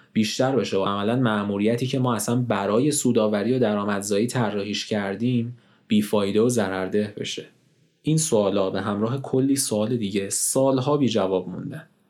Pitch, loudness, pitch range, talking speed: 110 Hz, -23 LUFS, 100-130 Hz, 145 wpm